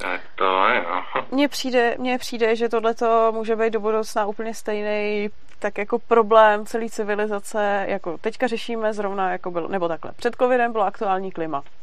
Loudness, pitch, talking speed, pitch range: -22 LUFS, 220 Hz, 150 wpm, 205-230 Hz